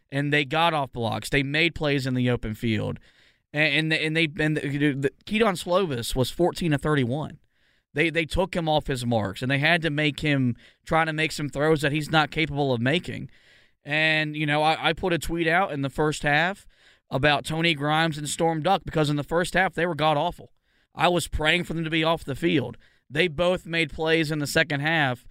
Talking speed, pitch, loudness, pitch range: 220 wpm, 155 Hz, -24 LUFS, 140-165 Hz